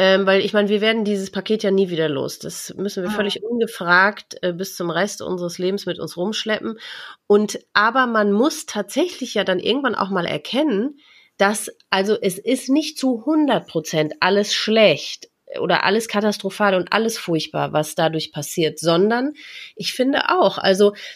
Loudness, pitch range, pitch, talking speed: -20 LUFS, 185-225 Hz, 205 Hz, 165 wpm